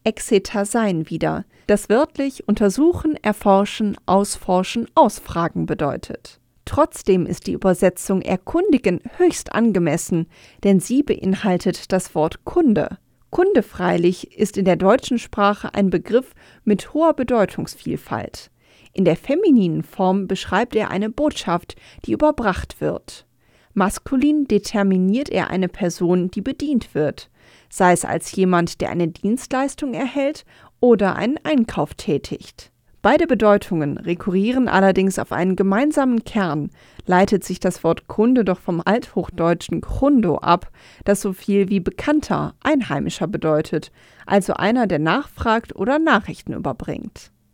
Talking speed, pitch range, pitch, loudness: 125 wpm, 180-245 Hz, 200 Hz, -19 LUFS